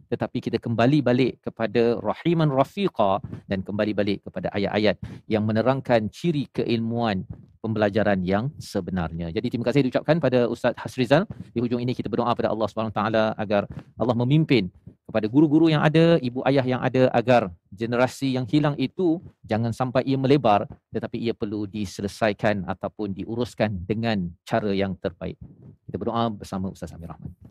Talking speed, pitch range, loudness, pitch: 155 wpm, 105-130 Hz, -24 LUFS, 115 Hz